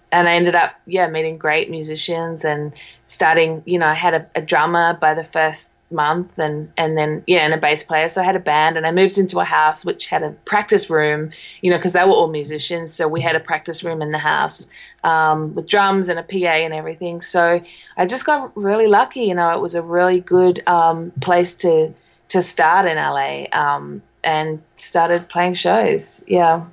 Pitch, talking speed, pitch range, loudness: 165 Hz, 215 wpm, 155-180 Hz, -17 LUFS